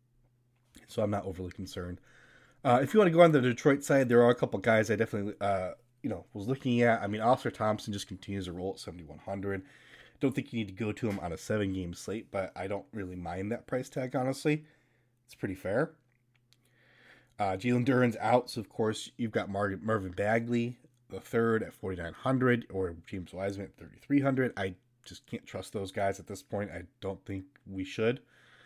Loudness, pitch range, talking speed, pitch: -31 LUFS, 95-125 Hz, 205 wpm, 115 Hz